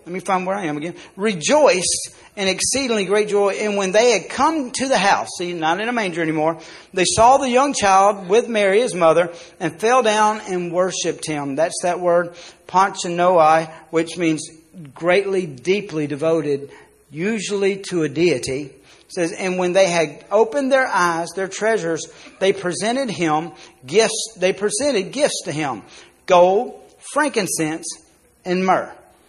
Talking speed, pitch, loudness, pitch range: 160 wpm, 185 Hz, -19 LUFS, 165-215 Hz